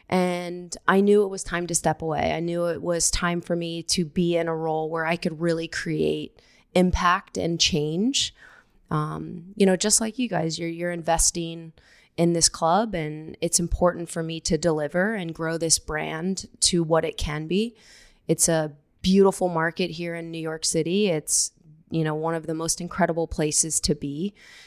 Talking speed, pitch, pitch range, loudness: 190 wpm, 170 Hz, 160-180 Hz, -24 LUFS